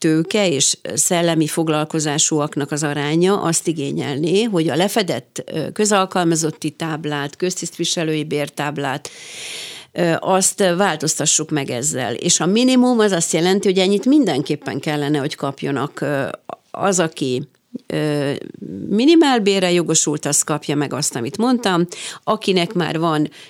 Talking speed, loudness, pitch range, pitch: 110 wpm, -18 LUFS, 145-190 Hz, 160 Hz